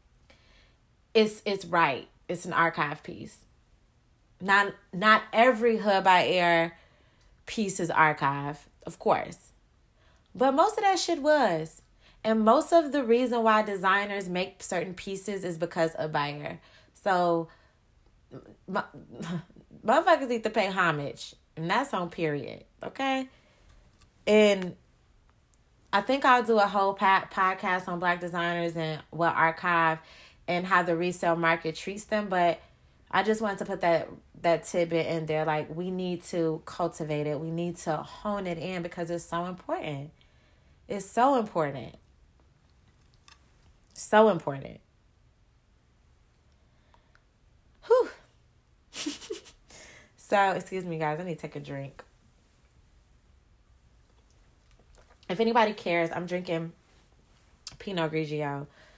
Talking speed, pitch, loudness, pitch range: 125 wpm, 175 Hz, -27 LUFS, 160-205 Hz